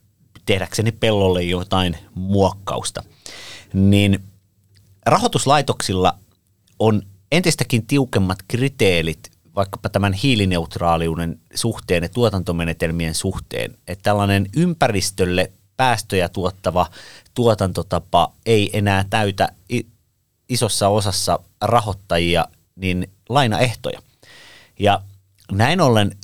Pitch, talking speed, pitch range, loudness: 100 Hz, 80 wpm, 90-110 Hz, -19 LUFS